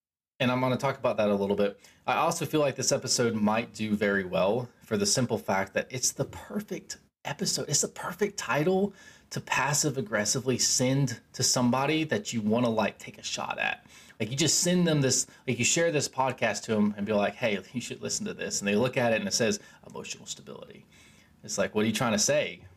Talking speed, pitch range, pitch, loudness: 230 wpm, 110-145 Hz, 130 Hz, -27 LUFS